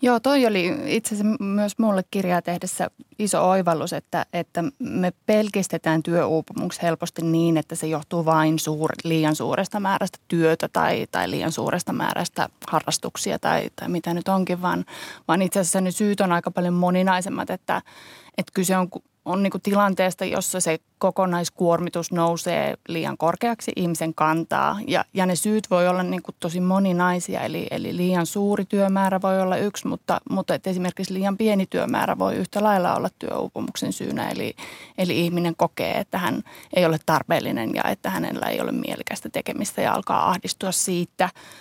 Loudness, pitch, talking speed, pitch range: -23 LUFS, 180 Hz, 165 wpm, 170-195 Hz